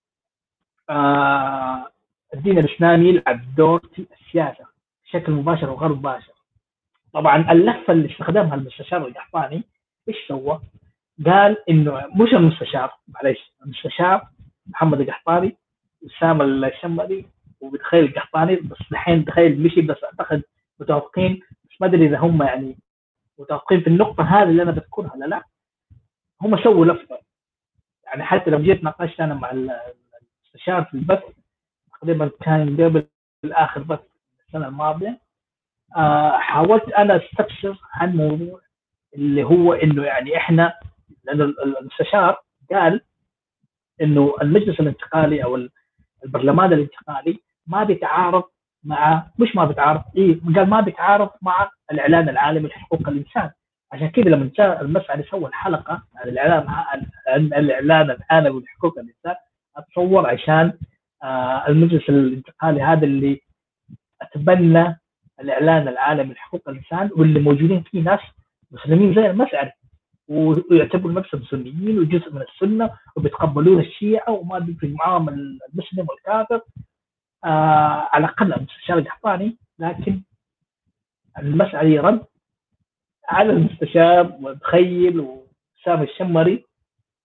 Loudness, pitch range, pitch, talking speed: -18 LUFS, 145-180 Hz, 160 Hz, 115 wpm